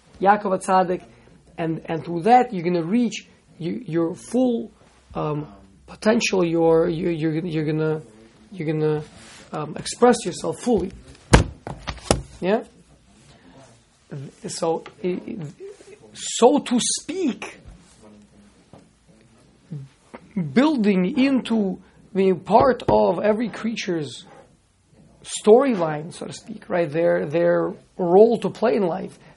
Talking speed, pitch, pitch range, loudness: 105 wpm, 185 Hz, 165-225 Hz, -21 LUFS